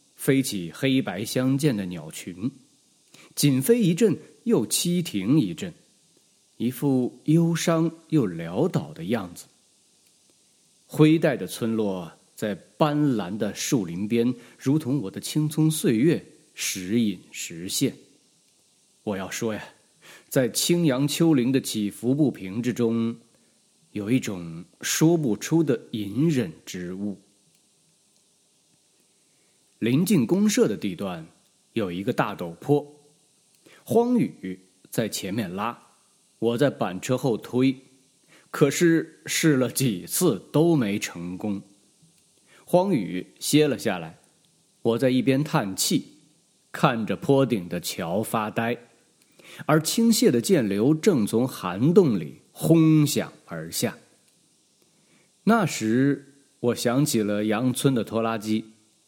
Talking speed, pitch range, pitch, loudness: 165 characters per minute, 110-155 Hz, 135 Hz, -24 LUFS